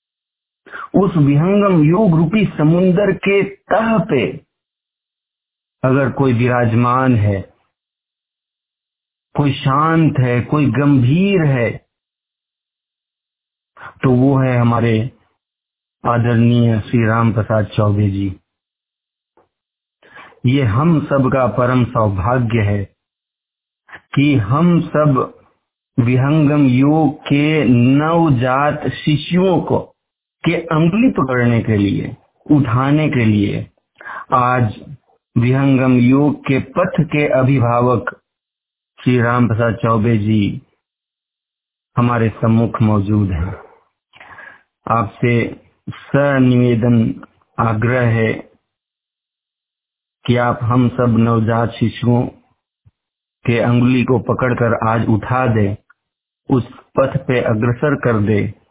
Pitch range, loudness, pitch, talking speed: 115-145 Hz, -15 LUFS, 125 Hz, 95 wpm